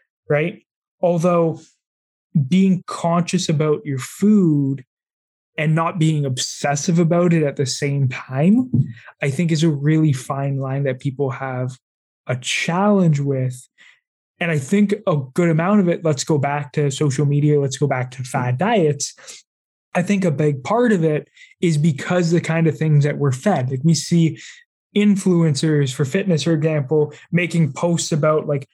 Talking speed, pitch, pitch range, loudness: 165 wpm, 155 Hz, 140-175 Hz, -19 LUFS